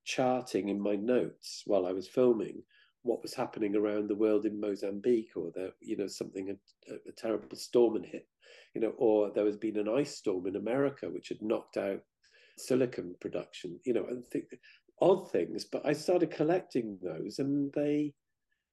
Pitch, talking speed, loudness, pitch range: 110 Hz, 185 wpm, -33 LUFS, 105-140 Hz